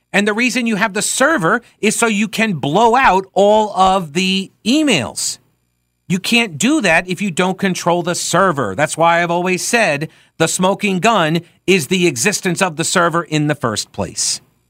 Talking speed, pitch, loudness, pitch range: 185 wpm, 185 Hz, -15 LUFS, 165-210 Hz